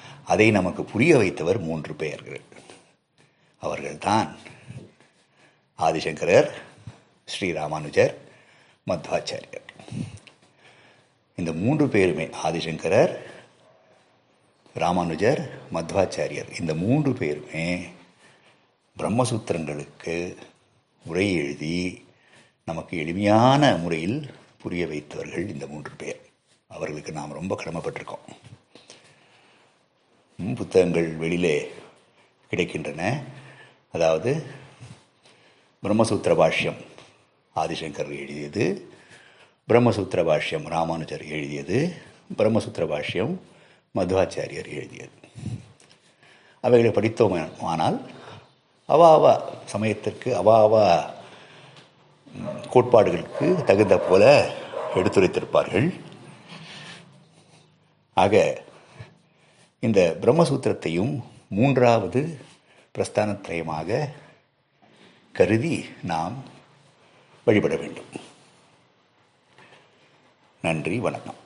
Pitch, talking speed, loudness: 110 Hz, 60 wpm, -23 LUFS